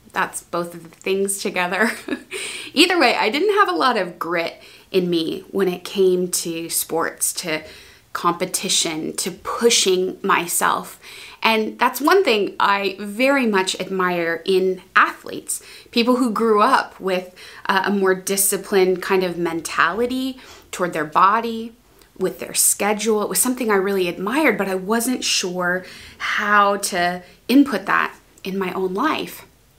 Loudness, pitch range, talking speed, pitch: -19 LUFS, 180-230 Hz, 145 wpm, 195 Hz